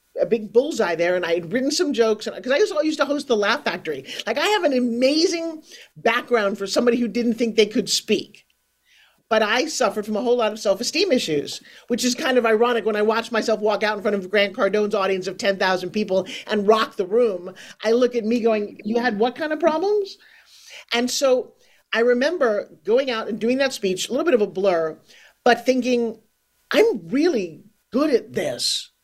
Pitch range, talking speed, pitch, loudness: 210-275 Hz, 210 wpm, 235 Hz, -21 LUFS